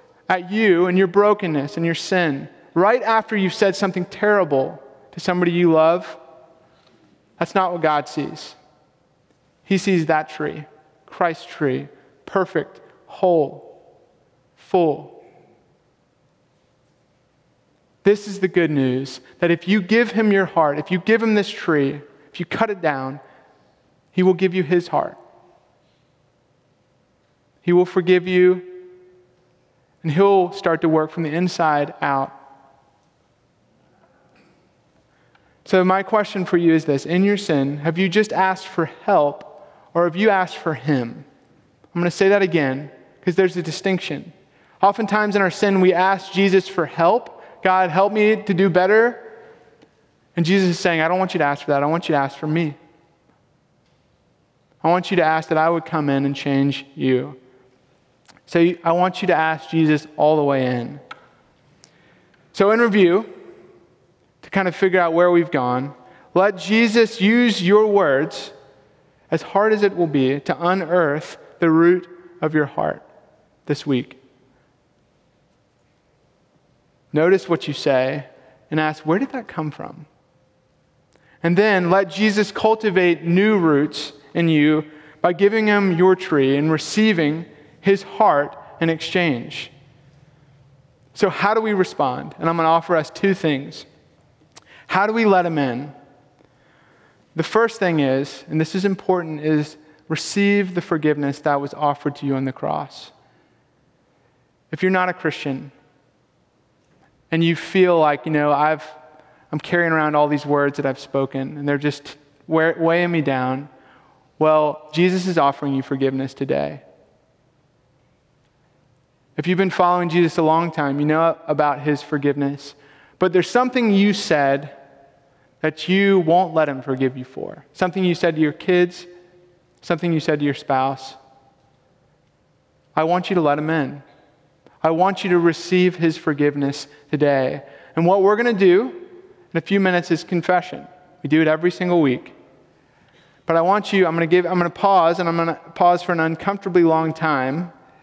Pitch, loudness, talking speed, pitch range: 165 Hz, -19 LUFS, 160 wpm, 145-185 Hz